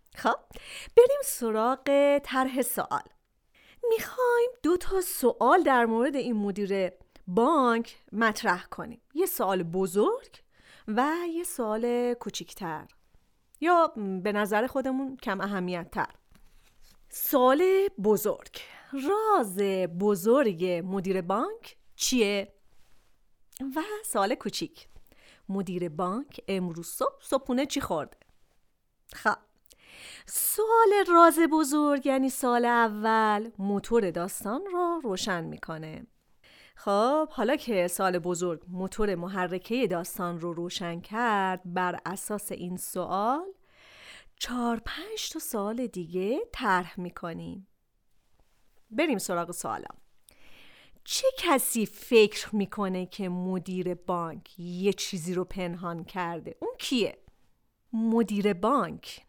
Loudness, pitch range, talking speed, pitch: -28 LUFS, 185-275 Hz, 100 wpm, 220 Hz